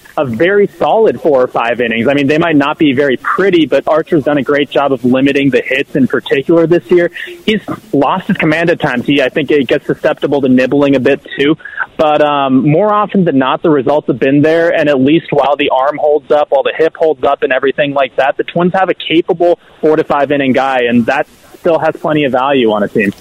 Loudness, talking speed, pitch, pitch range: -11 LUFS, 245 wpm, 150 Hz, 140-170 Hz